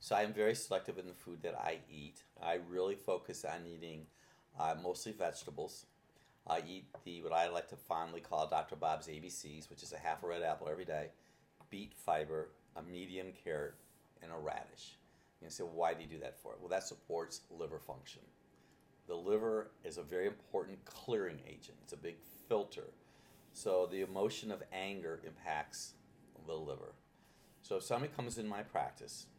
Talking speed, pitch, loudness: 185 wpm, 95 Hz, -42 LUFS